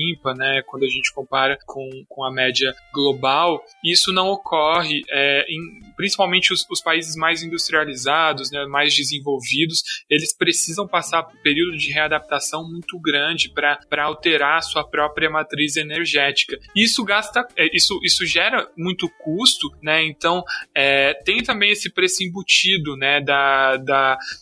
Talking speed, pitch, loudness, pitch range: 150 wpm, 155 Hz, -18 LUFS, 140-175 Hz